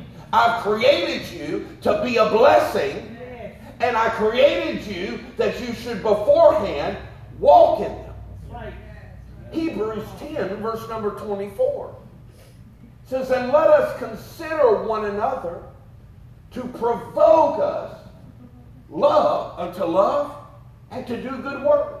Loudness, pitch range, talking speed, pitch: -20 LUFS, 215-295 Hz, 110 wpm, 235 Hz